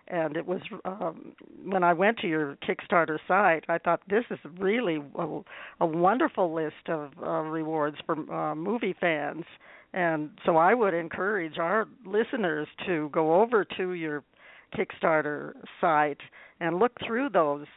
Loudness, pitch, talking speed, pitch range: -28 LUFS, 170 Hz, 150 wpm, 155-190 Hz